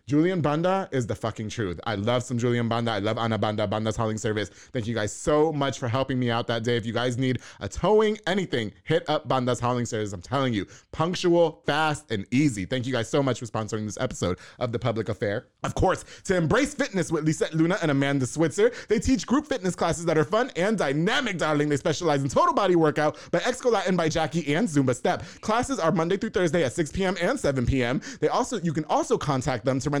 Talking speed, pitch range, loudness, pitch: 235 wpm, 120-170 Hz, -25 LUFS, 145 Hz